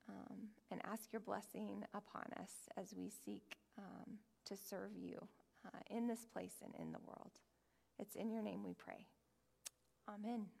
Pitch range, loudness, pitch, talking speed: 215-235 Hz, -52 LUFS, 225 Hz, 165 wpm